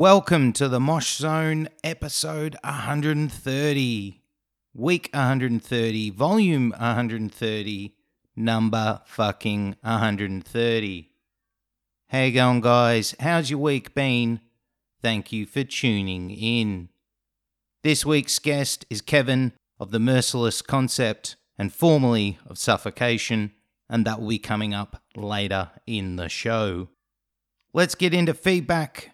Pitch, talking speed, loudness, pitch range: 120 Hz, 110 wpm, -23 LUFS, 105-145 Hz